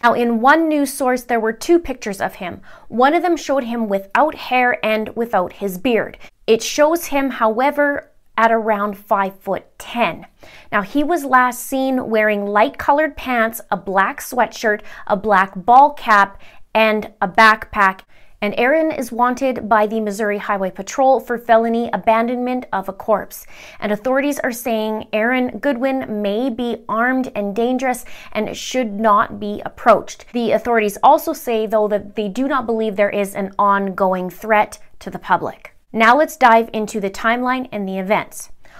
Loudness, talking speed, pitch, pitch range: -17 LUFS, 165 wpm, 225 Hz, 210-255 Hz